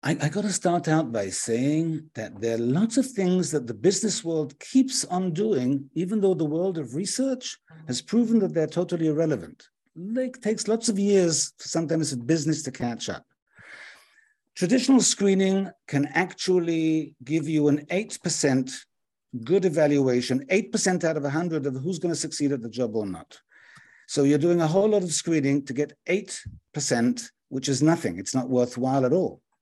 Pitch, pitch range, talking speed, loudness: 160 Hz, 145-195 Hz, 180 wpm, -25 LUFS